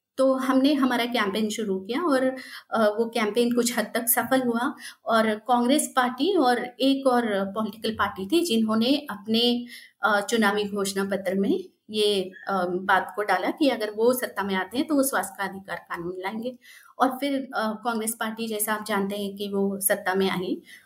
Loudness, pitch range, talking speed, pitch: -25 LUFS, 200-260 Hz, 175 wpm, 225 Hz